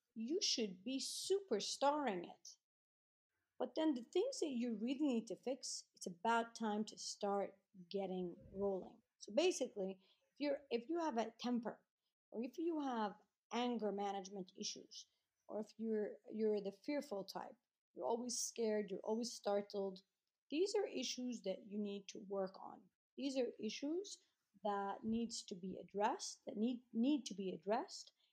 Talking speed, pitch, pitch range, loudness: 155 wpm, 225 Hz, 200-260 Hz, -43 LUFS